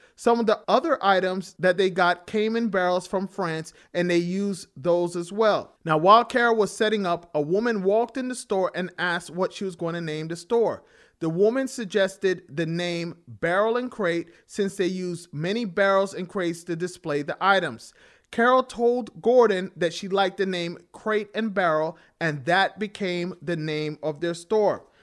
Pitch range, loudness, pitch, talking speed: 170-215 Hz, -24 LUFS, 185 Hz, 190 wpm